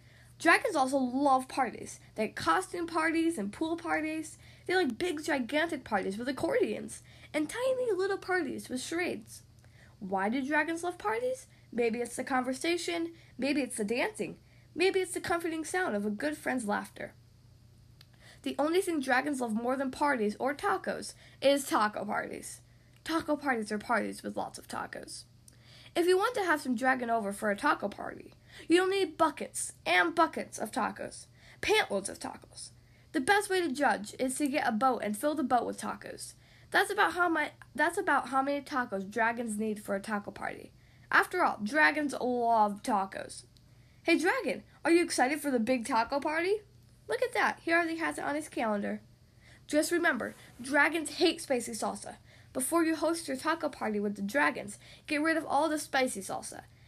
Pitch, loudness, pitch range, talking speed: 280 Hz, -31 LUFS, 225-330 Hz, 175 wpm